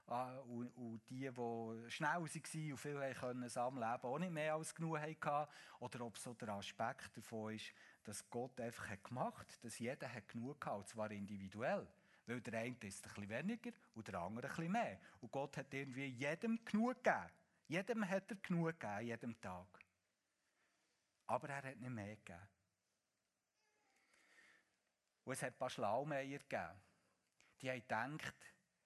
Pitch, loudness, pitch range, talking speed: 125 Hz, -46 LUFS, 115-150 Hz, 165 wpm